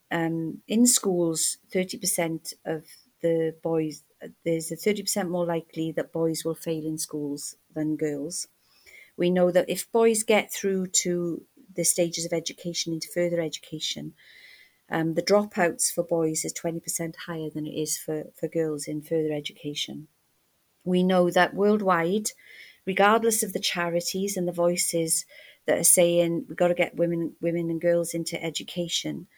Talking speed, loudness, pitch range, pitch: 165 wpm, -26 LUFS, 160-180 Hz, 170 Hz